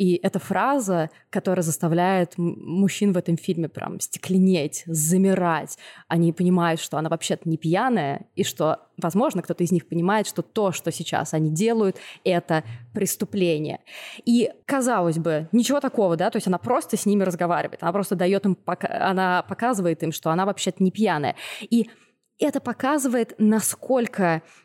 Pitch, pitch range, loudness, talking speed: 185 Hz, 170-215 Hz, -23 LUFS, 155 wpm